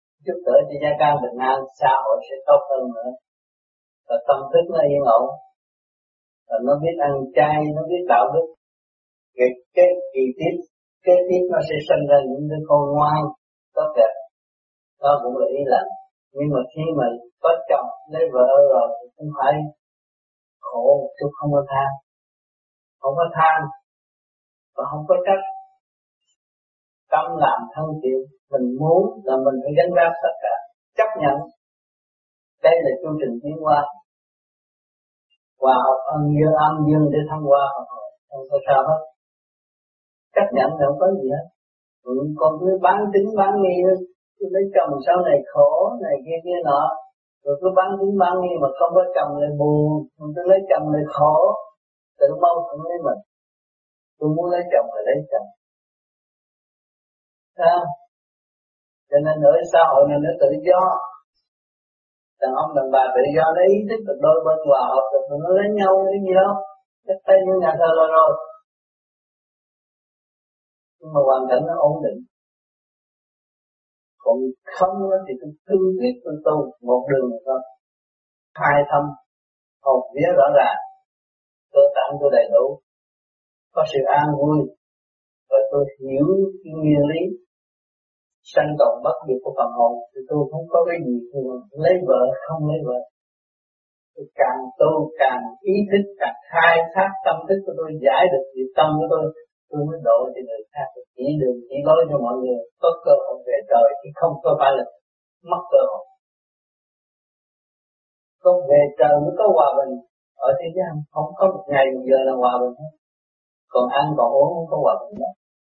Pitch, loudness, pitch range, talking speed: 155 Hz, -19 LUFS, 140-190 Hz, 170 wpm